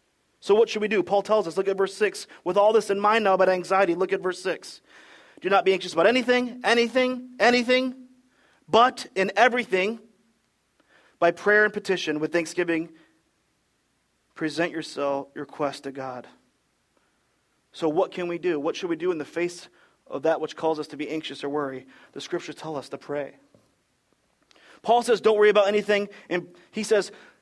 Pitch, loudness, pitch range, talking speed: 195 Hz, -24 LUFS, 165-220 Hz, 185 wpm